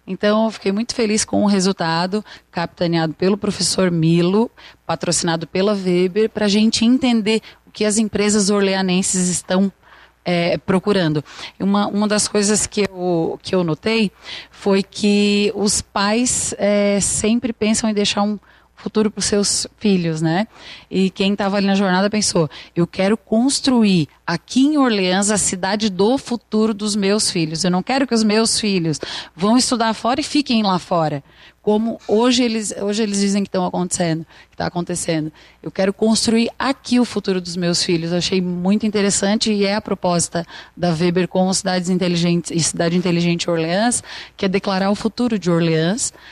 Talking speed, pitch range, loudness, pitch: 170 wpm, 180-215 Hz, -18 LUFS, 200 Hz